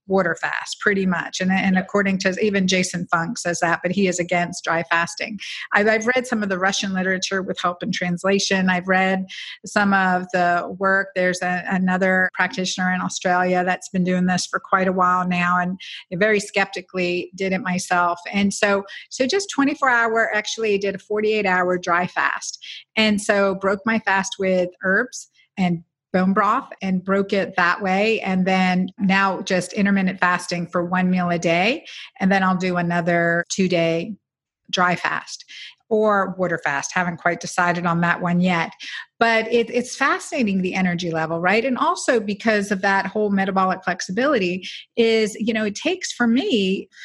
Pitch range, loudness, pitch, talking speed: 180-205 Hz, -20 LUFS, 190 Hz, 175 wpm